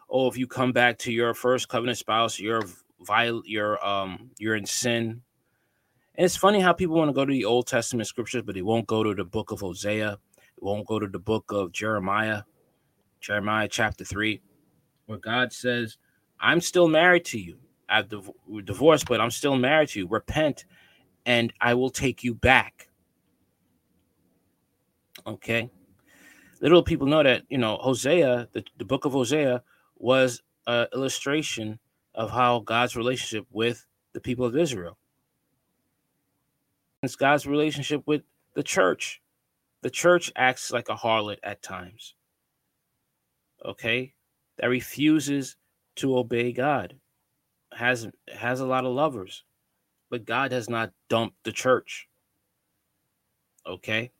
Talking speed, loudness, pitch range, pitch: 145 wpm, -25 LUFS, 110-135 Hz, 120 Hz